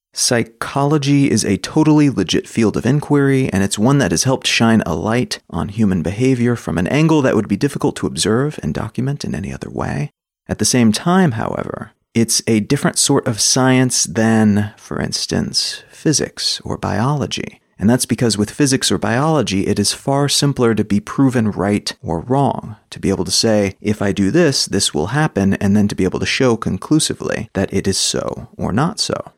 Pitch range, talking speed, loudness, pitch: 100-140 Hz, 195 wpm, -16 LUFS, 115 Hz